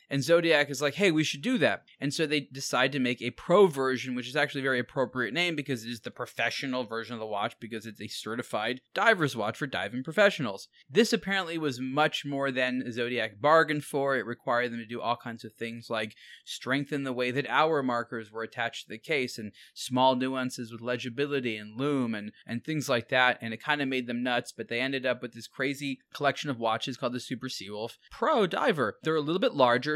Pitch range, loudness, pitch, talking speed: 120-145 Hz, -29 LUFS, 130 Hz, 225 wpm